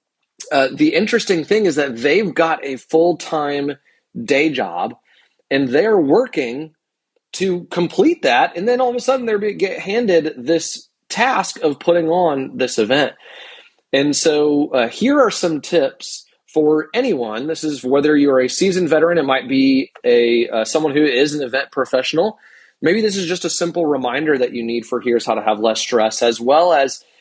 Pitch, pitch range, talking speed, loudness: 160 Hz, 140-195 Hz, 185 wpm, -17 LUFS